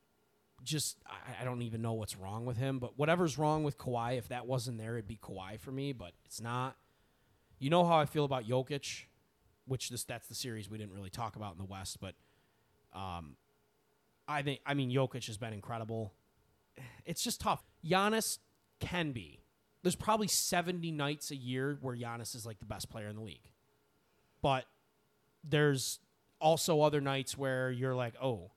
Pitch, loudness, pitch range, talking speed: 125 Hz, -36 LUFS, 110-145 Hz, 185 wpm